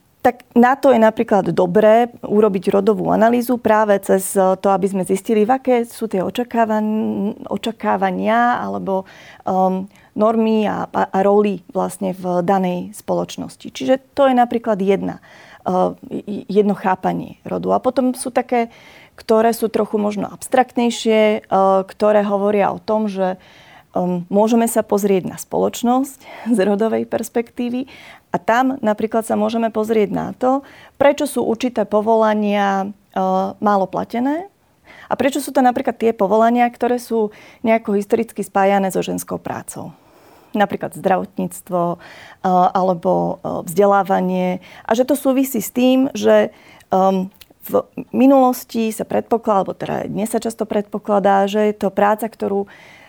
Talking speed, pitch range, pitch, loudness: 140 wpm, 195-235 Hz, 215 Hz, -18 LUFS